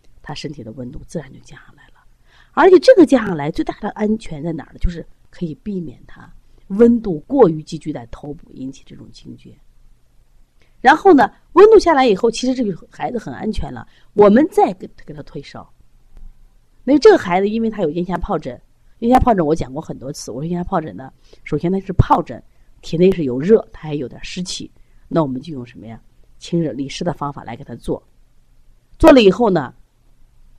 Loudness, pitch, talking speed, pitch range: -16 LUFS, 170 Hz, 290 characters per minute, 145-235 Hz